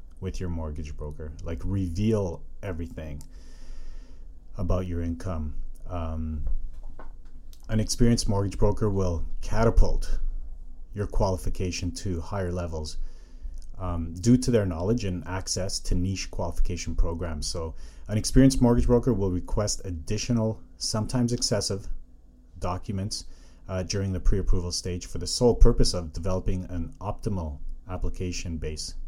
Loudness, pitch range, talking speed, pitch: -28 LUFS, 75-100 Hz, 125 wpm, 90 Hz